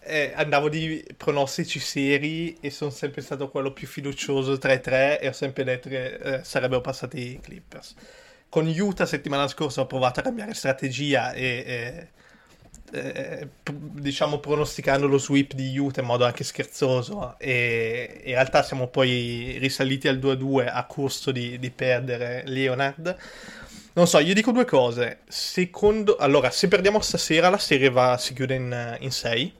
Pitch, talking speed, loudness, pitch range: 140 Hz, 160 wpm, -24 LUFS, 130-150 Hz